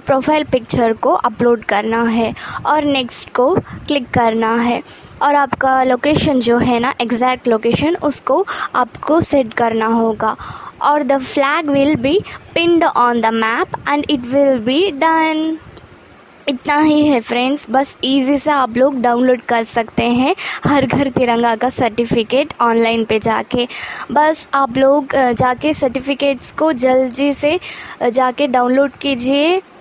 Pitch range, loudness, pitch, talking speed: 240-290 Hz, -15 LUFS, 265 Hz, 145 wpm